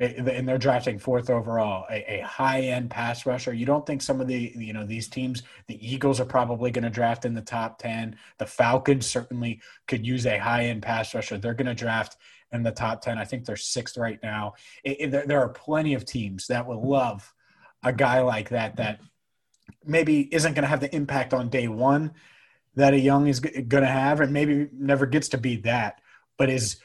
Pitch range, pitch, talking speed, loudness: 115-140 Hz, 125 Hz, 215 wpm, -25 LUFS